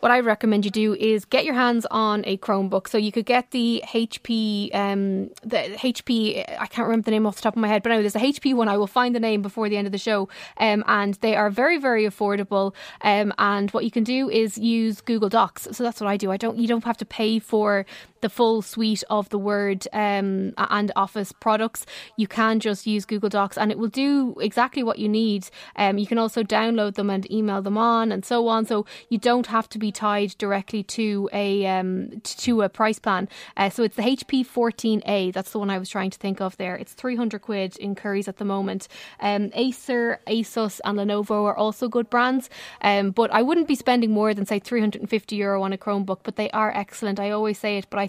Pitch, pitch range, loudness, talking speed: 215 Hz, 205-230 Hz, -23 LUFS, 240 wpm